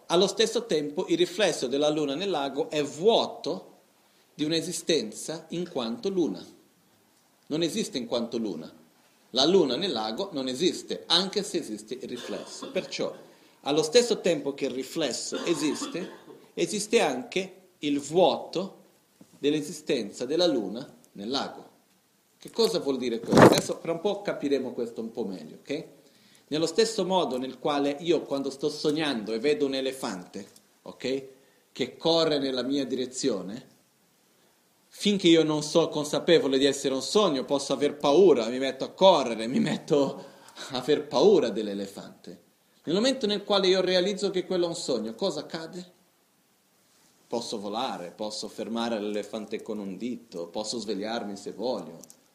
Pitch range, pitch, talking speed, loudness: 130-185 Hz, 150 Hz, 150 wpm, -27 LUFS